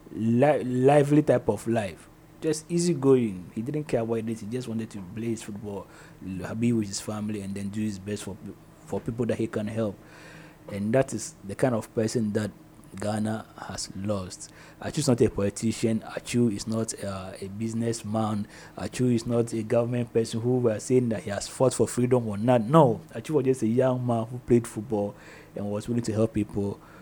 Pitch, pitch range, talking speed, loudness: 115 Hz, 105-125 Hz, 200 wpm, -27 LUFS